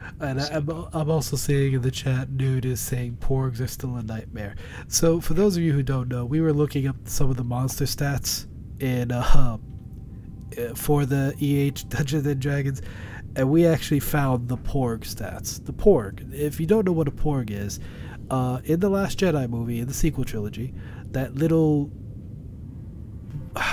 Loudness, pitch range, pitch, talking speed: -25 LUFS, 115-145 Hz, 130 Hz, 180 wpm